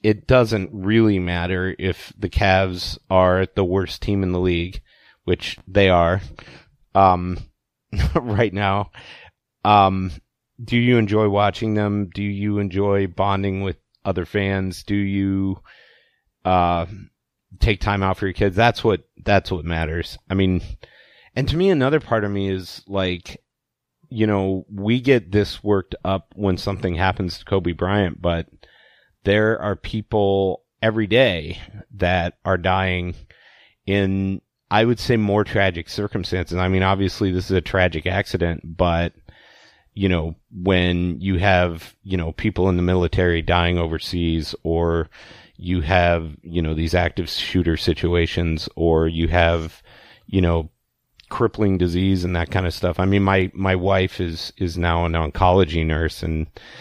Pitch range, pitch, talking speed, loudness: 85-100 Hz, 95 Hz, 150 wpm, -21 LUFS